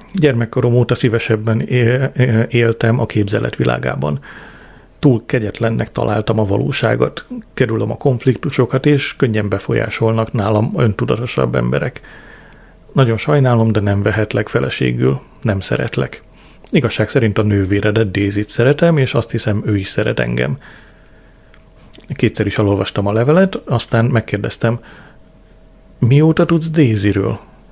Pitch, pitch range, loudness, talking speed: 115 Hz, 105-130 Hz, -16 LUFS, 115 wpm